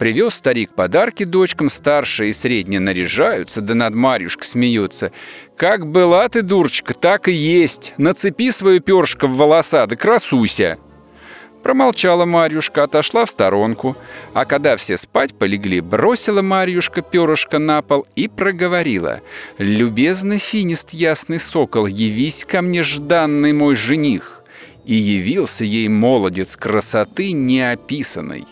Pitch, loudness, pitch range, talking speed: 150 Hz, -16 LUFS, 120-180 Hz, 125 wpm